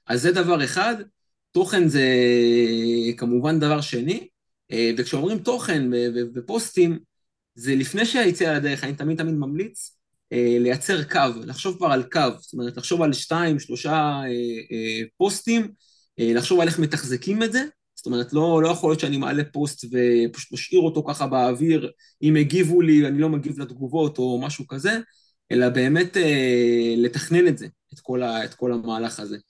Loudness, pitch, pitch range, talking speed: -22 LUFS, 145 Hz, 120-165 Hz, 150 wpm